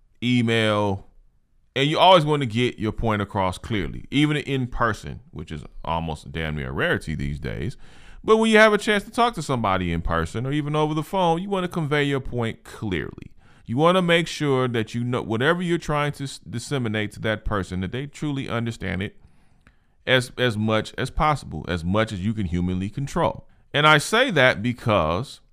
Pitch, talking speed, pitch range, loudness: 120 Hz, 200 wpm, 105-150 Hz, -23 LUFS